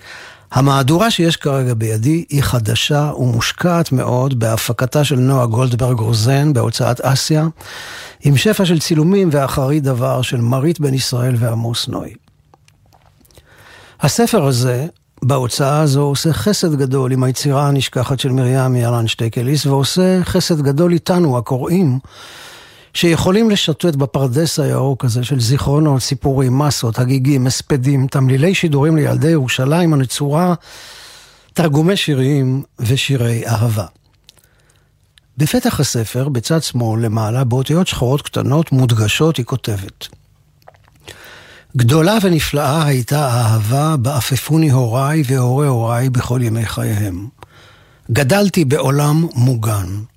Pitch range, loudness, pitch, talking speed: 125-150 Hz, -15 LUFS, 135 Hz, 110 wpm